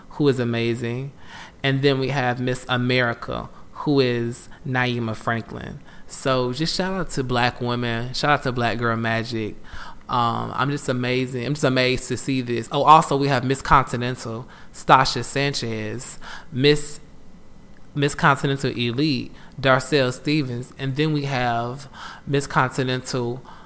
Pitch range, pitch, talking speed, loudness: 120-140 Hz, 130 Hz, 140 wpm, -22 LUFS